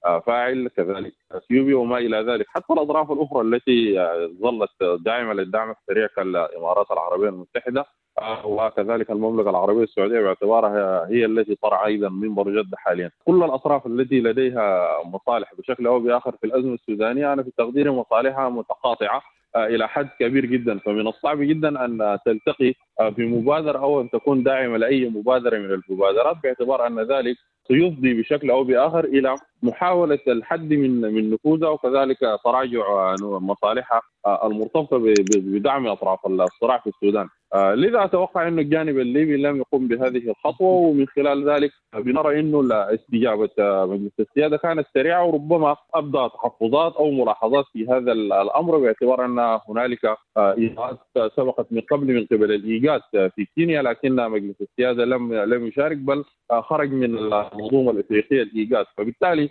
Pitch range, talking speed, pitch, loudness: 110-145 Hz, 140 wpm, 125 Hz, -21 LUFS